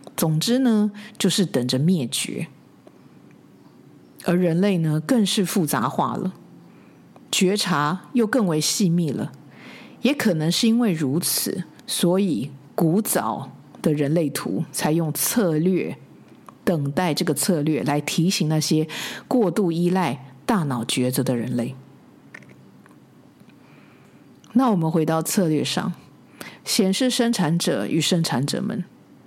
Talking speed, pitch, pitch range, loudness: 180 characters per minute, 175 Hz, 150-200 Hz, -22 LUFS